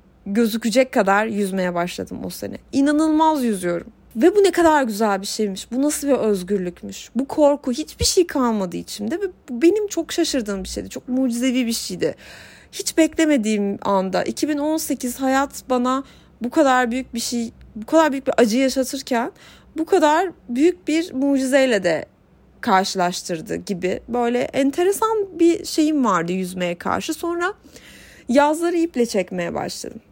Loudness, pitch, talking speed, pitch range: -20 LUFS, 260 Hz, 145 wpm, 210-315 Hz